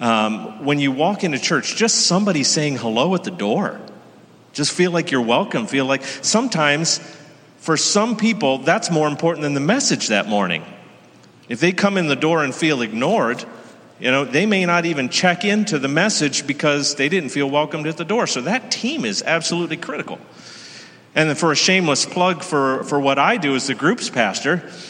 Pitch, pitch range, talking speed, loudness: 155 Hz, 140-185 Hz, 190 wpm, -18 LUFS